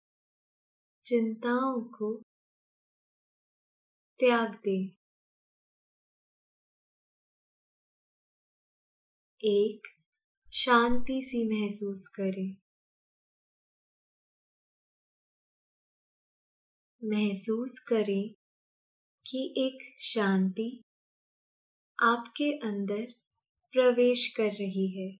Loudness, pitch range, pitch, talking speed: -30 LUFS, 205-250 Hz, 225 Hz, 45 wpm